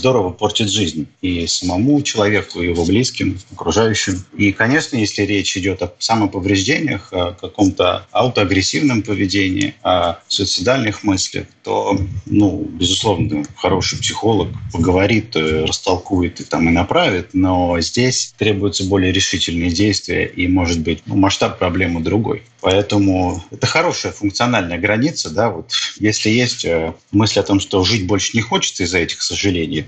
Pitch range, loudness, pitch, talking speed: 90-105 Hz, -16 LUFS, 100 Hz, 135 wpm